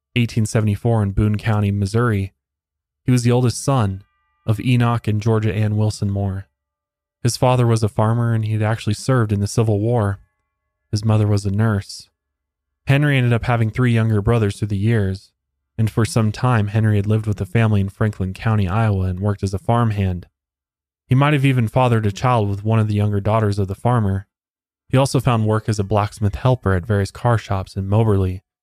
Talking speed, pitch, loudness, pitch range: 200 wpm, 105 Hz, -19 LUFS, 100-115 Hz